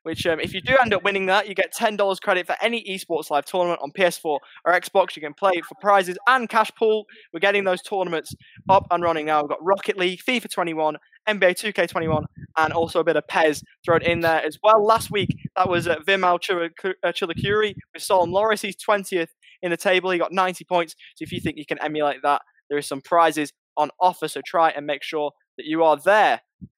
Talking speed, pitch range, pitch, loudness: 220 wpm, 160-195 Hz, 180 Hz, -22 LUFS